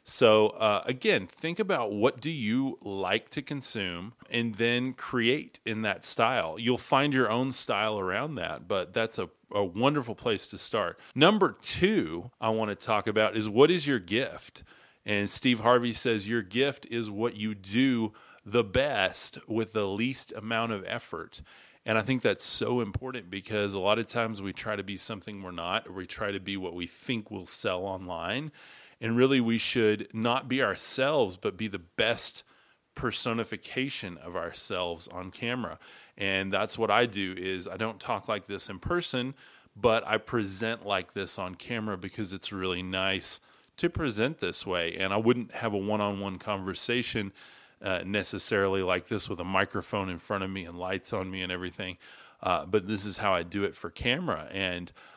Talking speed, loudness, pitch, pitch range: 185 wpm, -29 LUFS, 110 Hz, 95-120 Hz